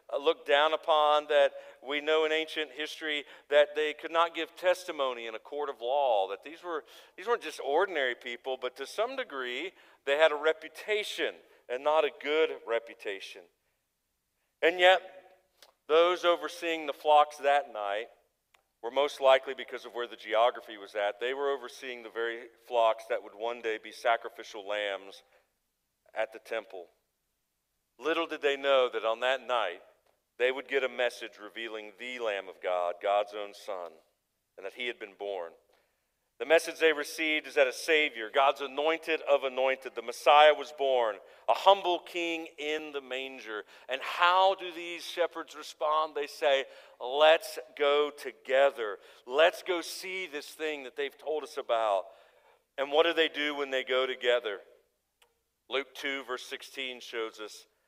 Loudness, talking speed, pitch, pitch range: -30 LUFS, 165 wpm, 145 Hz, 125-160 Hz